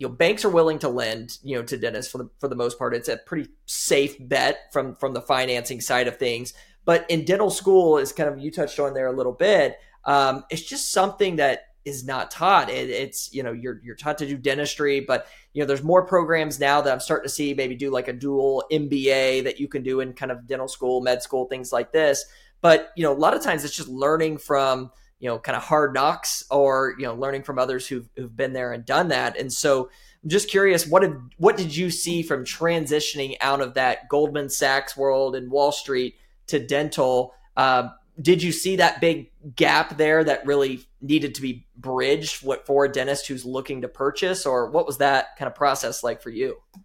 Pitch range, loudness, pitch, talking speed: 130-155 Hz, -23 LUFS, 140 Hz, 230 wpm